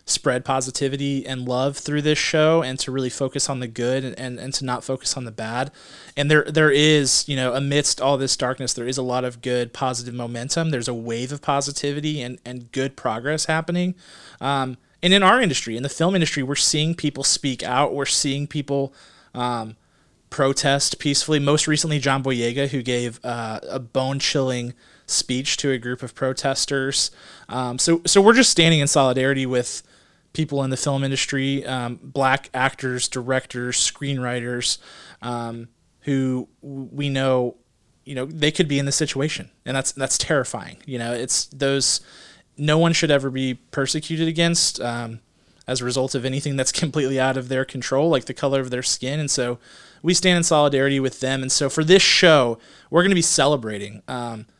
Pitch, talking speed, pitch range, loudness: 135 Hz, 190 wpm, 125-145 Hz, -21 LUFS